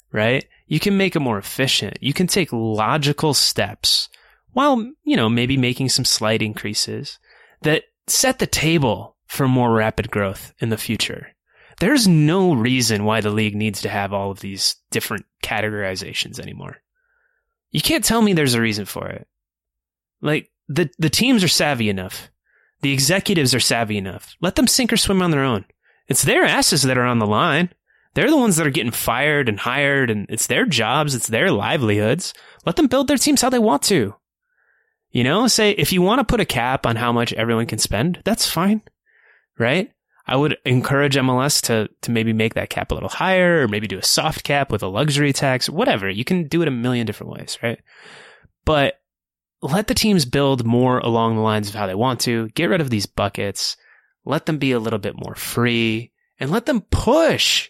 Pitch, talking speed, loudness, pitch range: 130 Hz, 200 wpm, -19 LUFS, 110-175 Hz